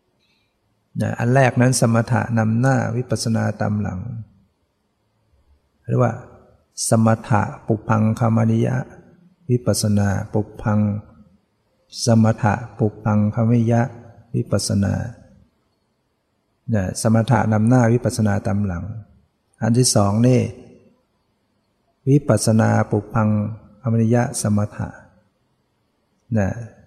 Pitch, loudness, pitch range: 110 Hz, -19 LUFS, 105-120 Hz